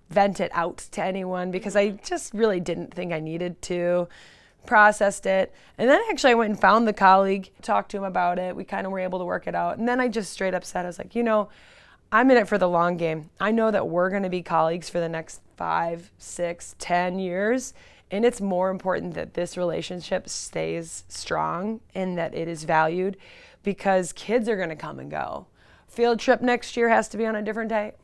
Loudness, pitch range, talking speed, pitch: -24 LUFS, 175-215 Hz, 225 wpm, 190 Hz